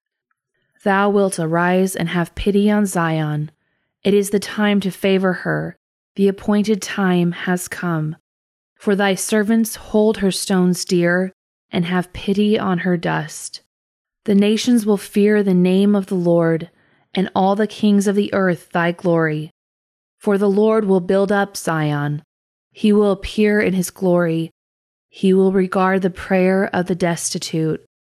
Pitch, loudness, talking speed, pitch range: 190 Hz, -18 LUFS, 155 wpm, 170-205 Hz